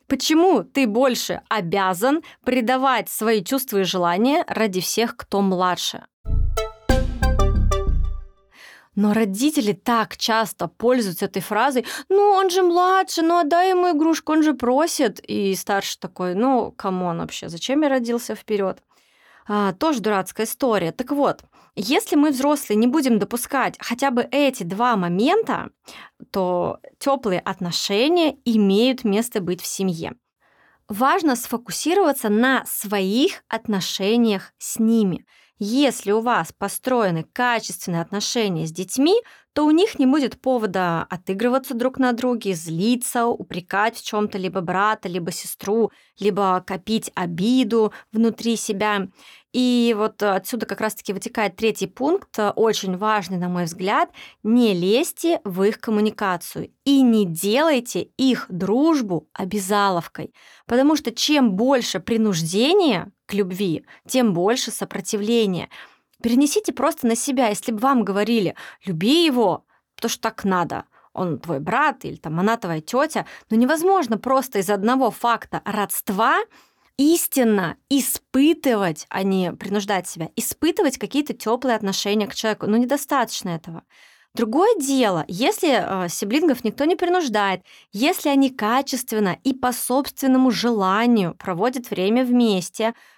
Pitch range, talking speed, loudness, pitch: 195-265 Hz, 130 wpm, -21 LUFS, 225 Hz